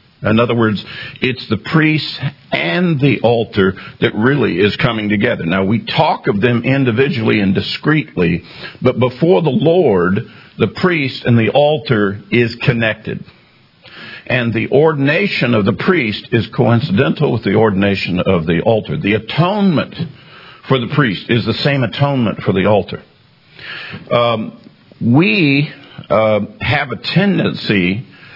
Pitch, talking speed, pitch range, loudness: 120 Hz, 140 wpm, 110-145 Hz, -14 LUFS